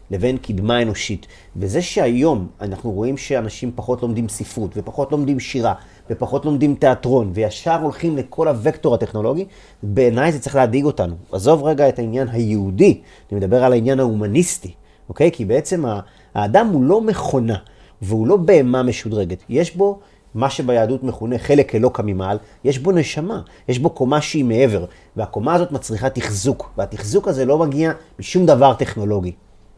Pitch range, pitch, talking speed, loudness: 105-140 Hz, 125 Hz, 155 wpm, -18 LUFS